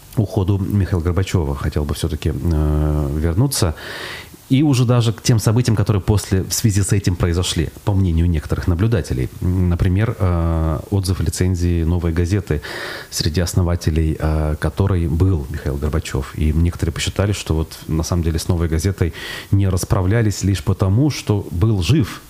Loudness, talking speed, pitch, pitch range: -19 LUFS, 145 wpm, 90 Hz, 80-105 Hz